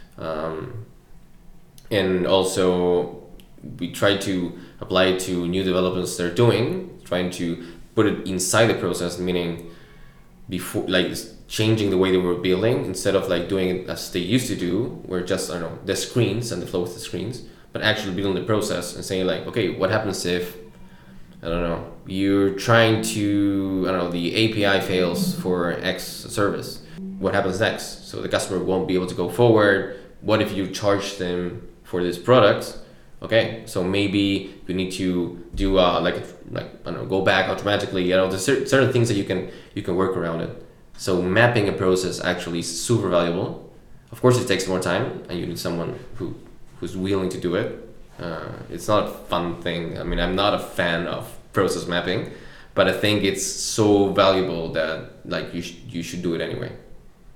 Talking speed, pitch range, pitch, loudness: 190 wpm, 90-100 Hz, 95 Hz, -22 LUFS